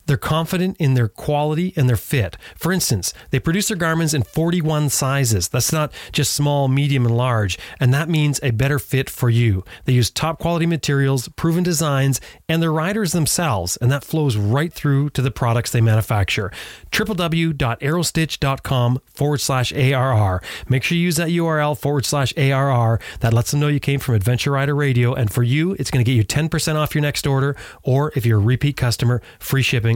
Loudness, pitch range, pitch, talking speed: -19 LUFS, 120-155 Hz, 140 Hz, 195 wpm